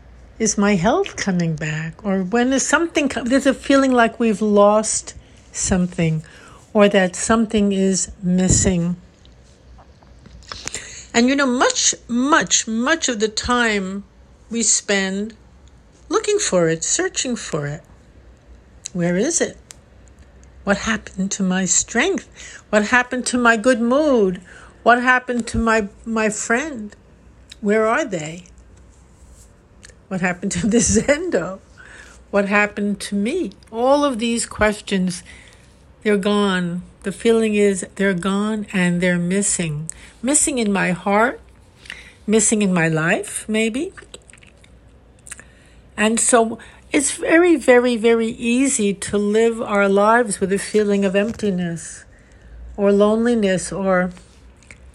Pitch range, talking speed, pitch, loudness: 185-235 Hz, 125 wpm, 210 Hz, -18 LUFS